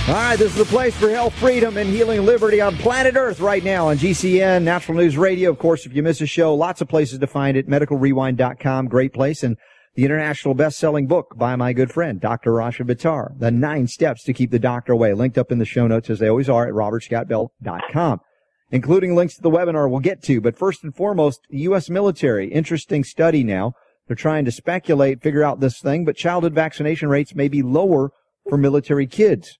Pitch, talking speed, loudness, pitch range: 150 Hz, 215 wpm, -19 LUFS, 130-175 Hz